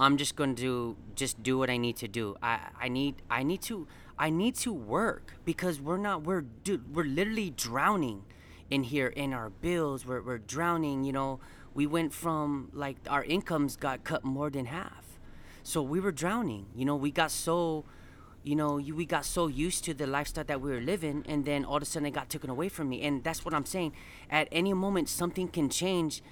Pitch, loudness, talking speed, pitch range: 145 Hz, -32 LUFS, 220 wpm, 135-165 Hz